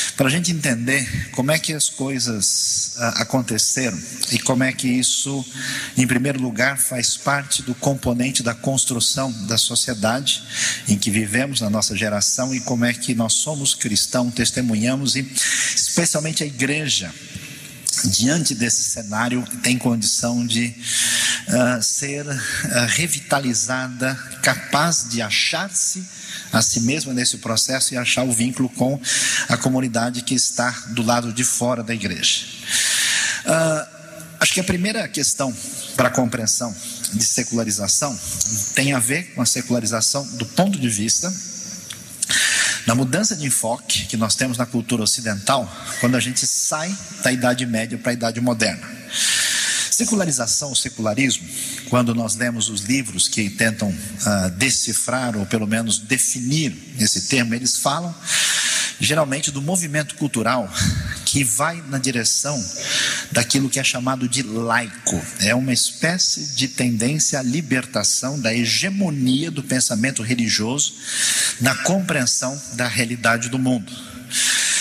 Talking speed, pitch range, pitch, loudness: 135 wpm, 115-135 Hz, 125 Hz, -19 LUFS